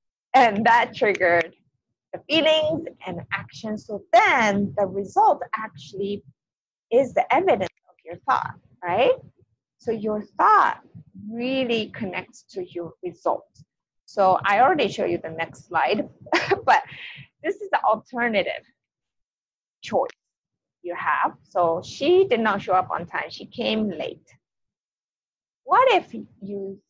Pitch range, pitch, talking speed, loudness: 195-315 Hz, 215 Hz, 125 wpm, -22 LUFS